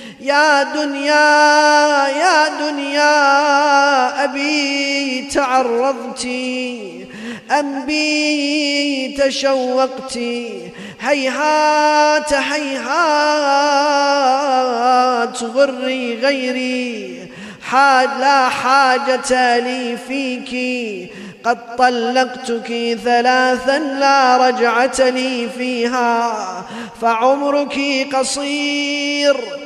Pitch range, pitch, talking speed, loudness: 250-285 Hz, 265 Hz, 55 wpm, -15 LUFS